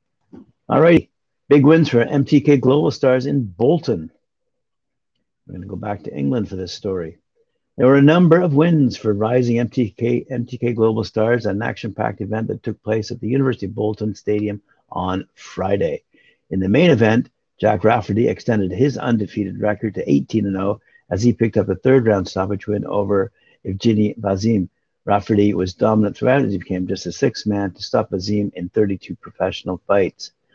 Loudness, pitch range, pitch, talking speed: -18 LUFS, 100-125 Hz, 105 Hz, 175 wpm